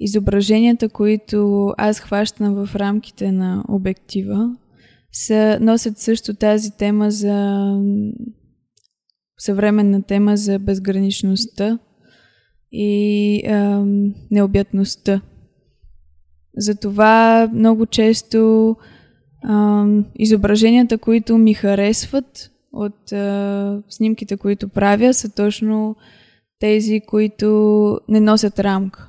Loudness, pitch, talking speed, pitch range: -16 LUFS, 210 Hz, 85 wpm, 200-220 Hz